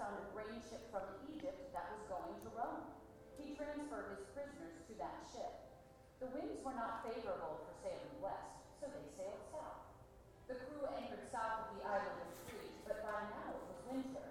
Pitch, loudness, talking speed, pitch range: 265 Hz, -48 LUFS, 190 wpm, 225-285 Hz